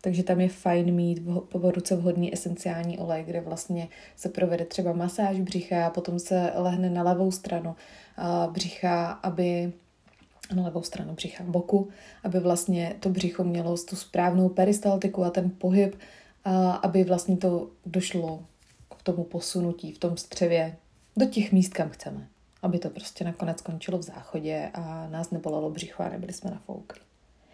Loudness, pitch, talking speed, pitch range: -28 LUFS, 180 Hz, 160 wpm, 170-185 Hz